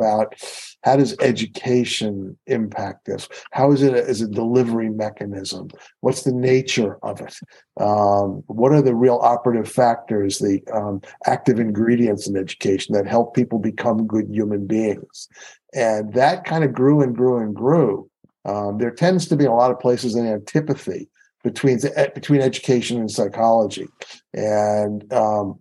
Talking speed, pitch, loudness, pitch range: 155 wpm, 115 Hz, -19 LUFS, 105-130 Hz